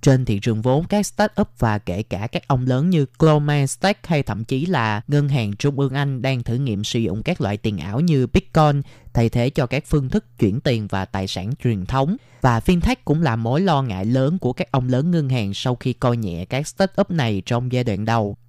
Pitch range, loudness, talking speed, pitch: 115-150 Hz, -20 LUFS, 235 wpm, 130 Hz